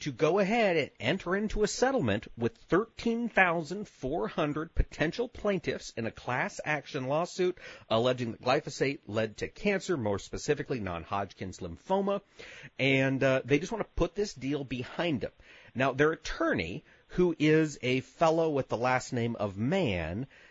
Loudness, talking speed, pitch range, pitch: -30 LUFS, 150 wpm, 125-185 Hz, 150 Hz